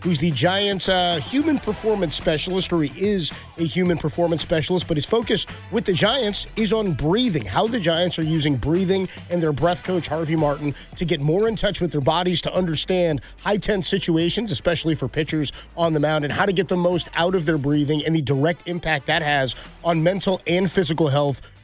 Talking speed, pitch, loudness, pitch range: 210 wpm, 170 Hz, -21 LUFS, 155-190 Hz